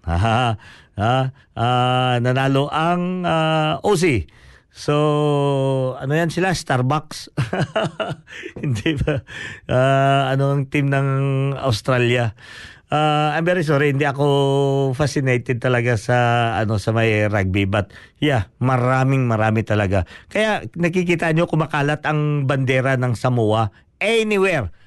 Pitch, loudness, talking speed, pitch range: 135 Hz, -19 LUFS, 115 wpm, 120-150 Hz